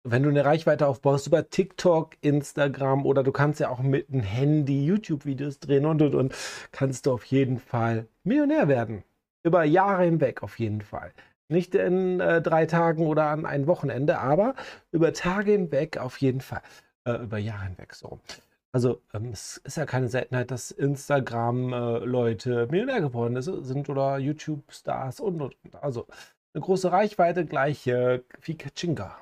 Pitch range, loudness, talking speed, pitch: 125-160 Hz, -26 LUFS, 165 wpm, 140 Hz